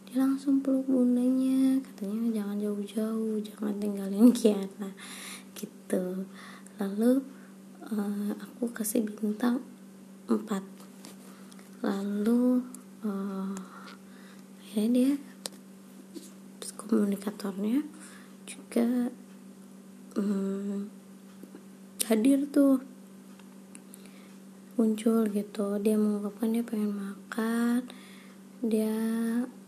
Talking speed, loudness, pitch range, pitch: 70 wpm, -29 LUFS, 200-230 Hz, 210 Hz